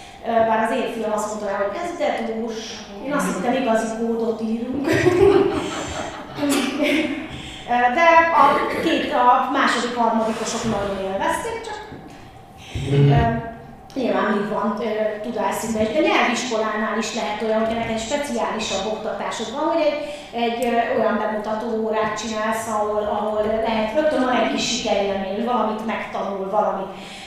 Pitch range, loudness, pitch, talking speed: 210-250 Hz, -21 LUFS, 225 Hz, 120 wpm